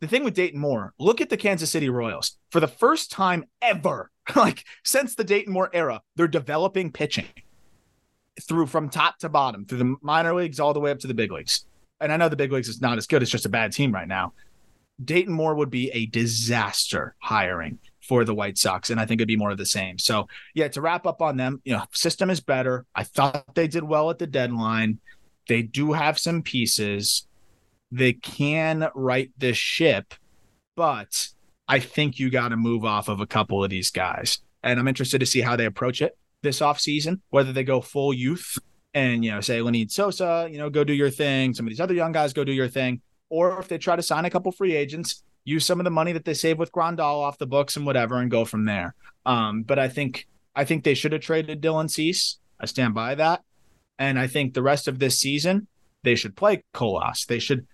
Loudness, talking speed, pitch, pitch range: -24 LUFS, 230 wpm, 140 Hz, 120-160 Hz